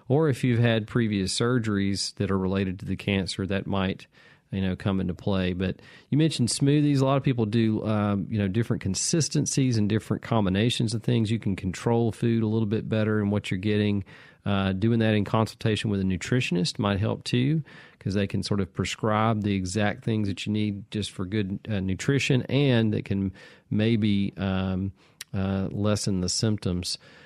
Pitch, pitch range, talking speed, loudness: 105 Hz, 100-115 Hz, 190 wpm, -26 LUFS